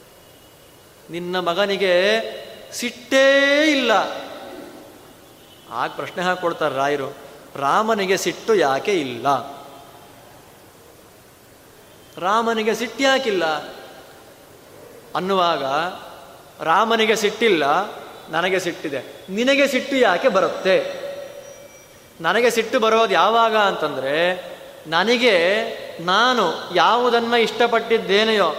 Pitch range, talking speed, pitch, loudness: 170-245 Hz, 70 wpm, 210 Hz, -19 LUFS